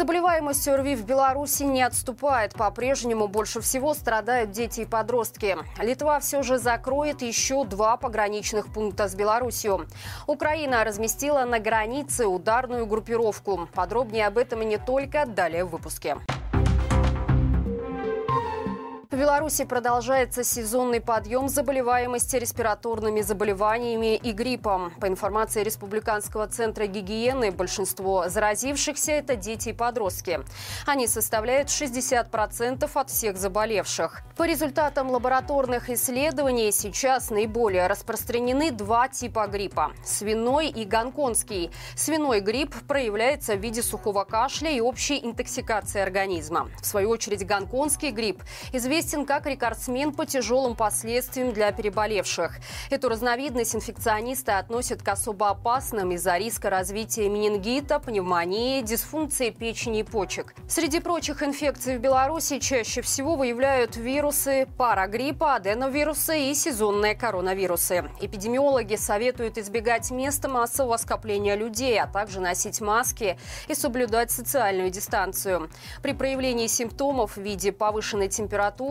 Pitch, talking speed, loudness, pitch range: 235 Hz, 115 wpm, -25 LUFS, 210-270 Hz